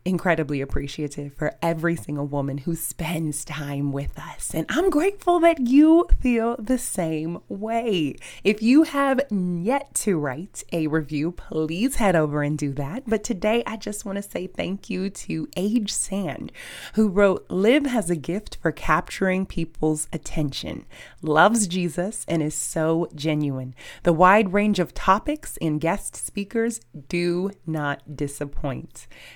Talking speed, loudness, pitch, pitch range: 150 wpm, -23 LUFS, 175 Hz, 155-215 Hz